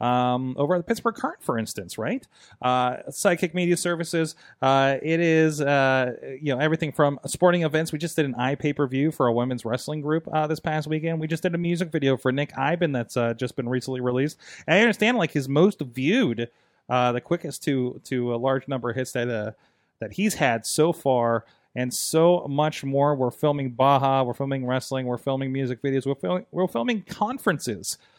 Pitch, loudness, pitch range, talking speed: 140 Hz, -24 LUFS, 130-165 Hz, 205 wpm